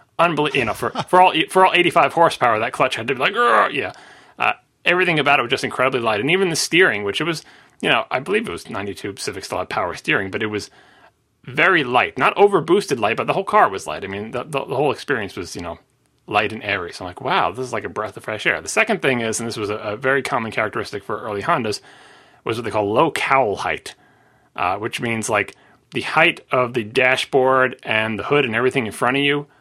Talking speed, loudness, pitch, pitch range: 250 wpm, -19 LUFS, 140 Hz, 115-175 Hz